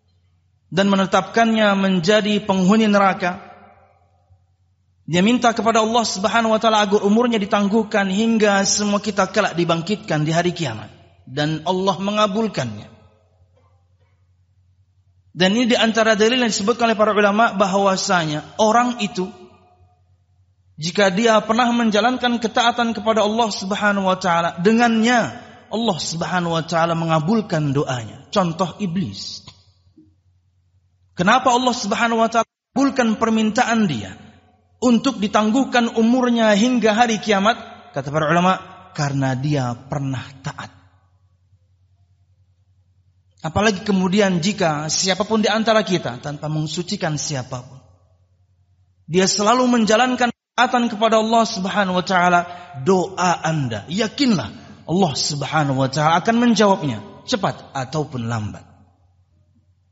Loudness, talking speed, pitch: -18 LUFS, 110 wpm, 180 Hz